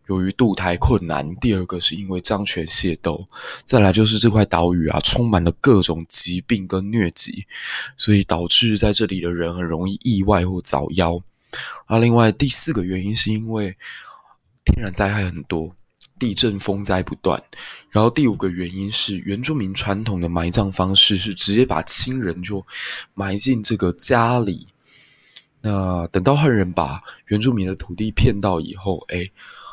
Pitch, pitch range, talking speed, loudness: 100 Hz, 90-110 Hz, 250 characters per minute, -17 LUFS